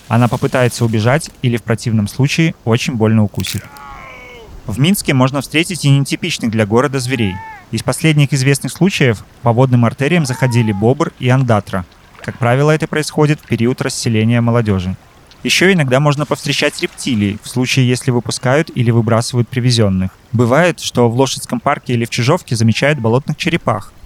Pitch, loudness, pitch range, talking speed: 125 Hz, -14 LUFS, 115-145 Hz, 150 wpm